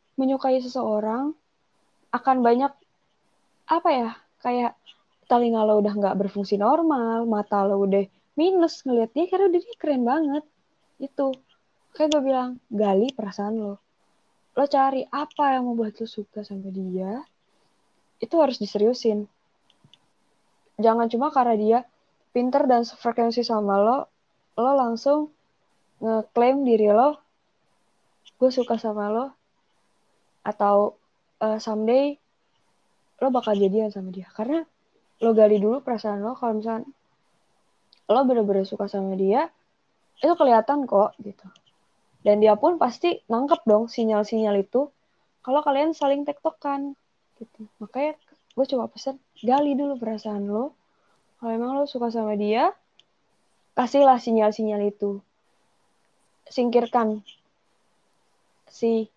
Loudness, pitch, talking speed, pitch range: -23 LUFS, 235 Hz, 120 wpm, 215-275 Hz